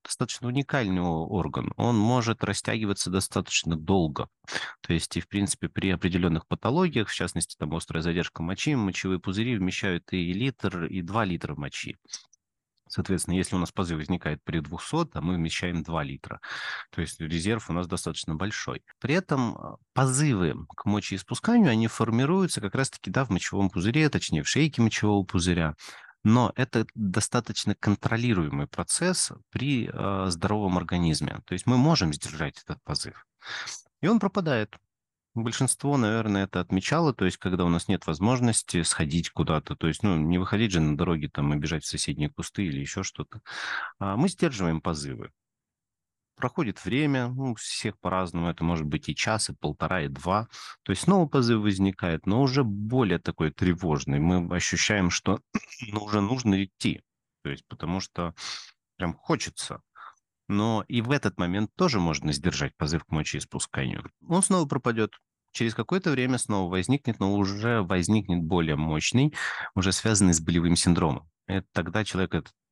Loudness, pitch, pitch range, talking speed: -27 LUFS, 95 Hz, 85-120 Hz, 160 wpm